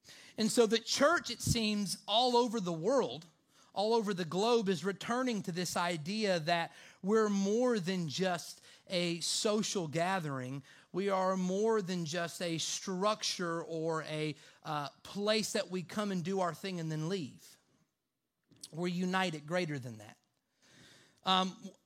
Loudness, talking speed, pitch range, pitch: -34 LUFS, 150 wpm, 165-210 Hz, 185 Hz